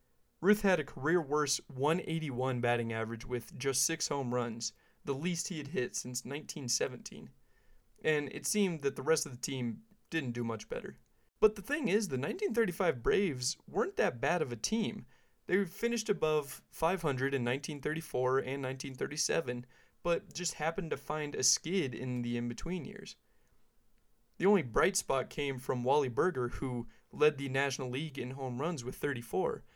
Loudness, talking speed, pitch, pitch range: -34 LUFS, 165 wpm, 145 Hz, 130-180 Hz